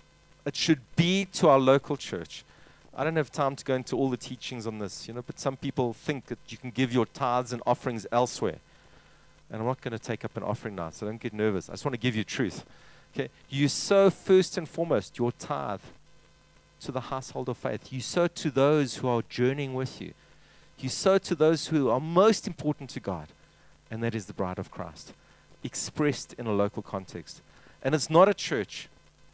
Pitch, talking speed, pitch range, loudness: 130 Hz, 215 wpm, 115-150 Hz, -28 LUFS